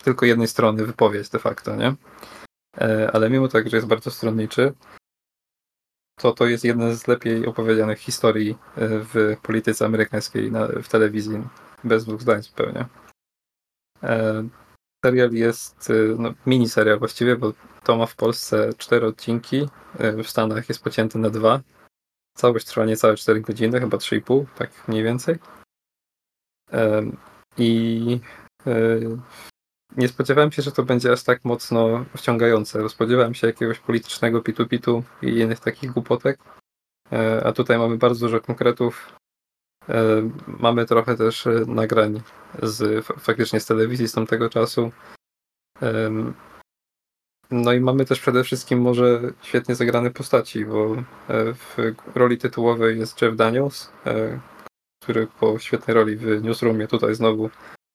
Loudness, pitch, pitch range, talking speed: -21 LUFS, 115 Hz, 110-120 Hz, 125 wpm